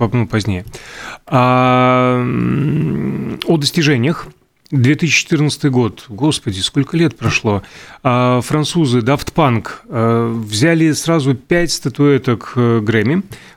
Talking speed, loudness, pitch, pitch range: 75 wpm, -15 LUFS, 125 Hz, 115-150 Hz